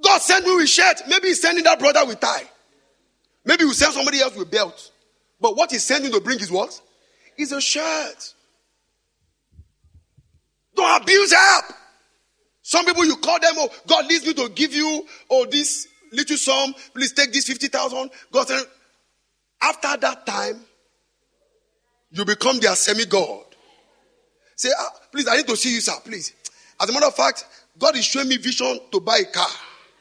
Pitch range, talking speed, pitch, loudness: 260-350 Hz, 170 wpm, 295 Hz, -18 LUFS